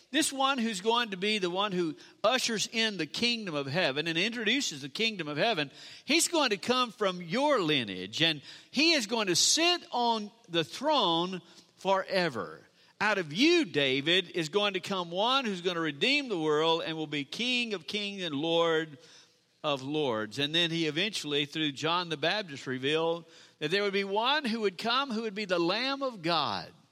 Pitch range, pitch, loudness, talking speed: 160-225 Hz, 185 Hz, -29 LUFS, 195 wpm